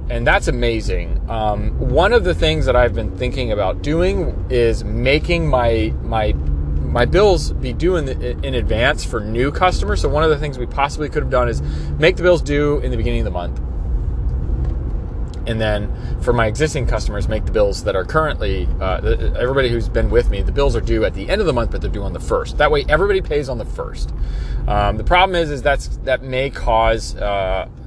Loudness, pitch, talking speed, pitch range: -18 LUFS, 110 Hz, 215 wpm, 90-130 Hz